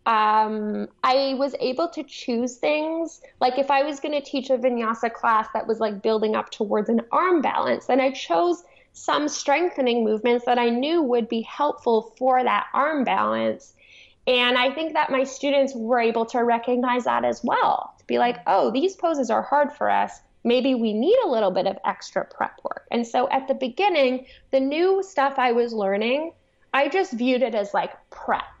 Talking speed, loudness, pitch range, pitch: 195 wpm, -23 LUFS, 235-285 Hz, 255 Hz